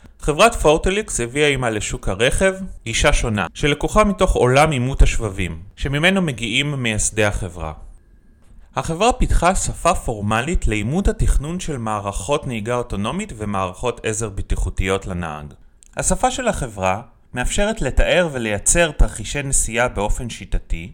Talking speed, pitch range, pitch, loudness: 120 wpm, 100-150 Hz, 120 Hz, -20 LUFS